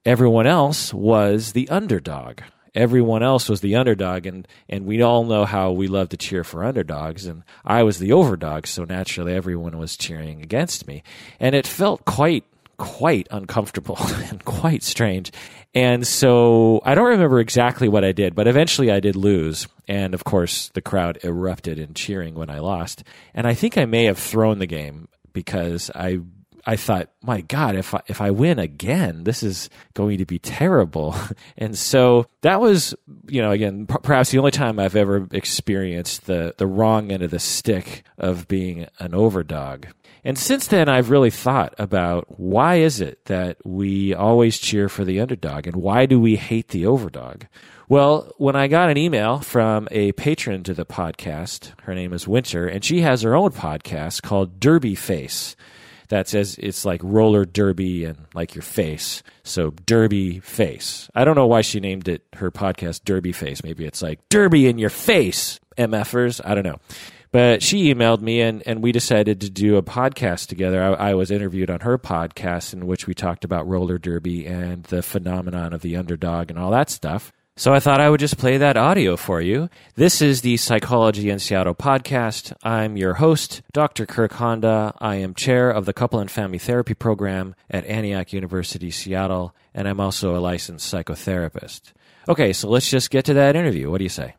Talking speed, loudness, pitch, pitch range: 190 wpm, -20 LUFS, 105 Hz, 90-120 Hz